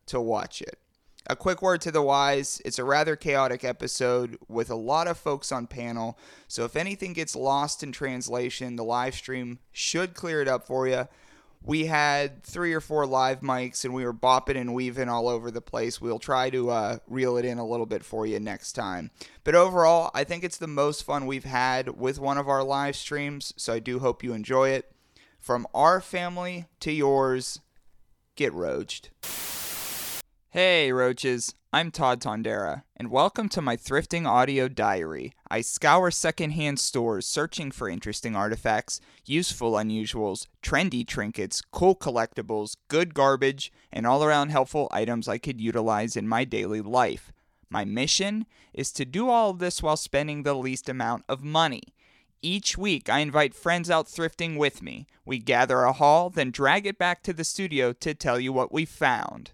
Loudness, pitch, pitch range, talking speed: -26 LUFS, 135 Hz, 125-155 Hz, 180 wpm